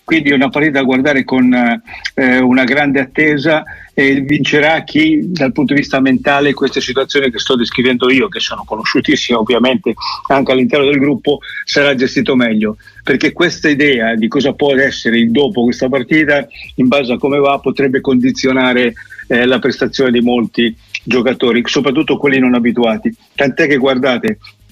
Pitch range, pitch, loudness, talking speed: 125-145 Hz, 135 Hz, -12 LUFS, 165 wpm